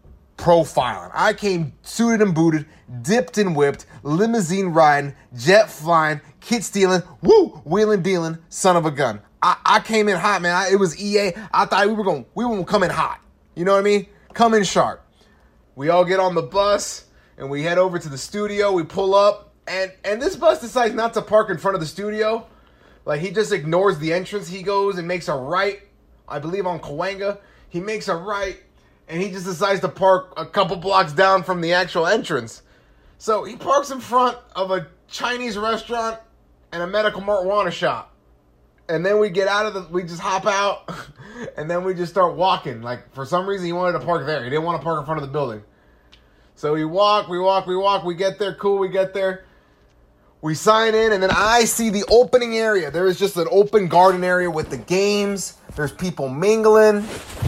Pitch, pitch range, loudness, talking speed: 190 Hz, 165-205 Hz, -19 LUFS, 210 wpm